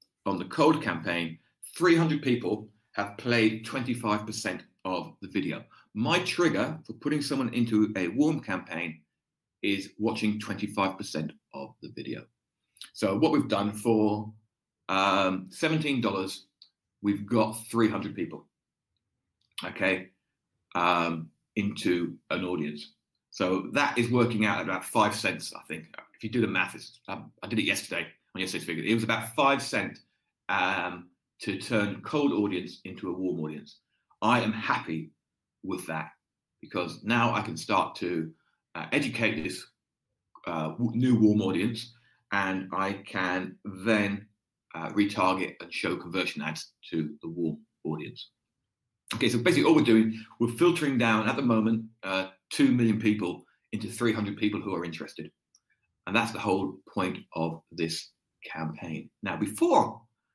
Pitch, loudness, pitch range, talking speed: 105 Hz, -28 LUFS, 95-115 Hz, 145 wpm